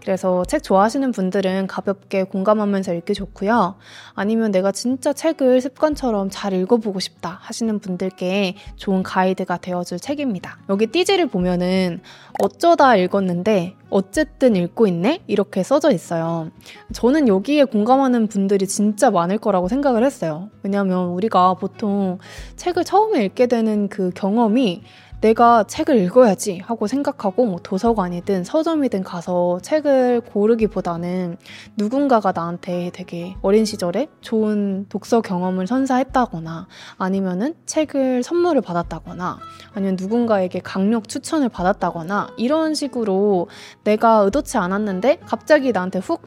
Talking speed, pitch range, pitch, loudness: 330 characters per minute, 185-250 Hz, 205 Hz, -19 LUFS